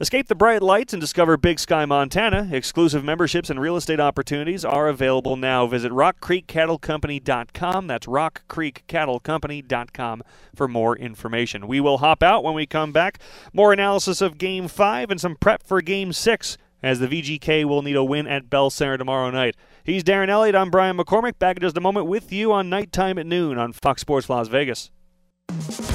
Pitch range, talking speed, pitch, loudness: 135-185 Hz, 180 wpm, 160 Hz, -21 LUFS